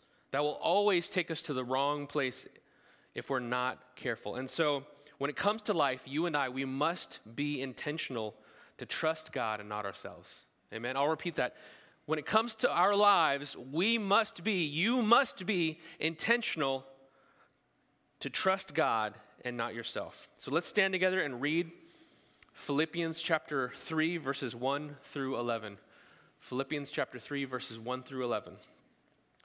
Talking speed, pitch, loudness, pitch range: 155 wpm, 145 Hz, -33 LUFS, 130-170 Hz